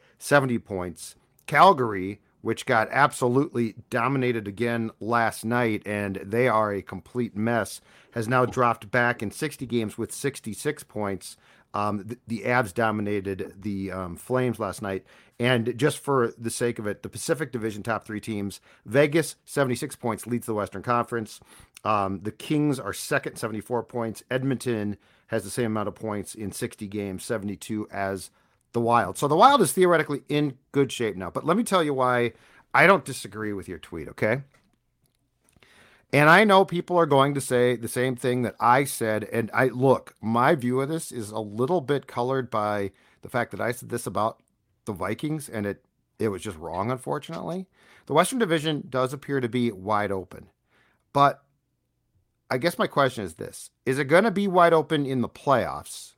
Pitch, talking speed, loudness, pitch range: 120 Hz, 180 wpm, -25 LUFS, 105-135 Hz